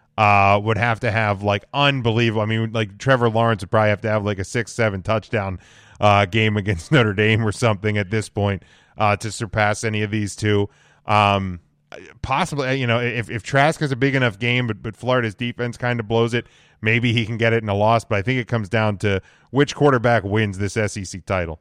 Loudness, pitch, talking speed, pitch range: -20 LUFS, 110 Hz, 220 wpm, 105-120 Hz